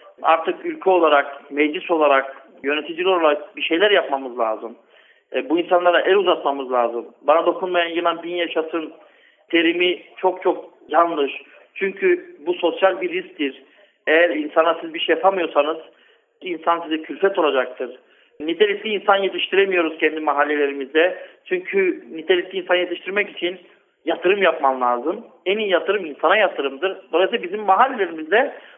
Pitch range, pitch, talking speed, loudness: 150-195 Hz, 170 Hz, 125 wpm, -20 LUFS